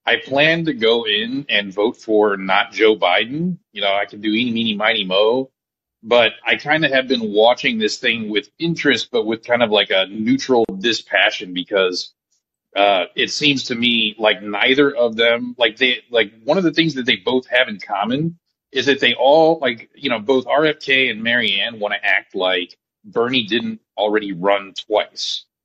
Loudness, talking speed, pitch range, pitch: -17 LUFS, 190 wpm, 105-145 Hz, 120 Hz